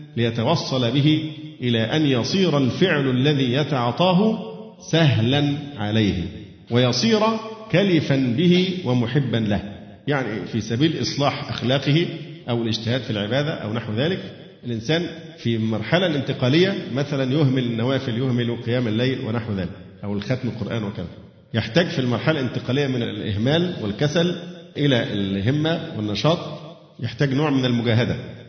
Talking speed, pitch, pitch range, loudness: 120 wpm, 130 Hz, 115-160 Hz, -21 LUFS